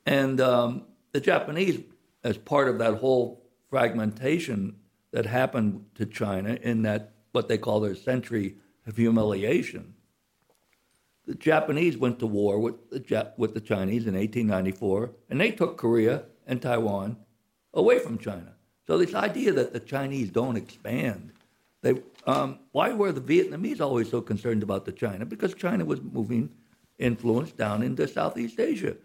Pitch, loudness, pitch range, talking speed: 115 Hz, -27 LUFS, 105-130 Hz, 155 wpm